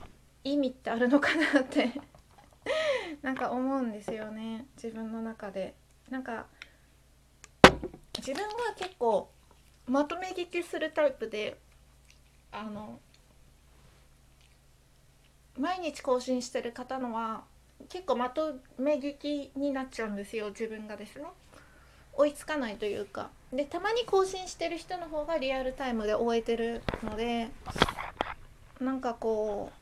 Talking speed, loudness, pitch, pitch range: 245 characters per minute, -31 LUFS, 260 Hz, 225-300 Hz